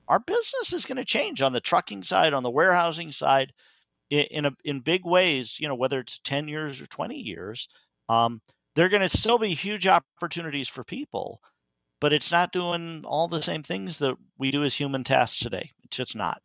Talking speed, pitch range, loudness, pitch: 210 wpm, 135-180 Hz, -26 LUFS, 155 Hz